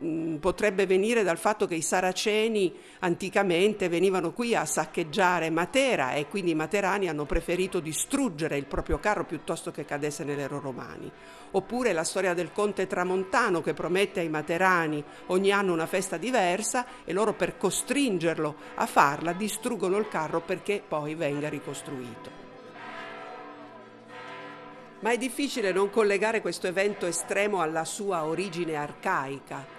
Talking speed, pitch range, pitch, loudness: 140 wpm, 160-205 Hz, 180 Hz, -27 LUFS